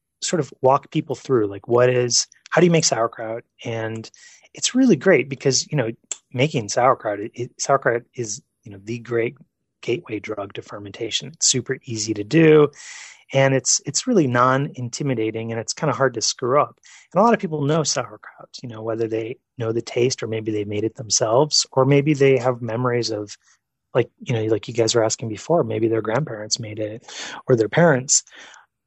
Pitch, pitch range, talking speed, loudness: 125 Hz, 110-140 Hz, 195 wpm, -20 LUFS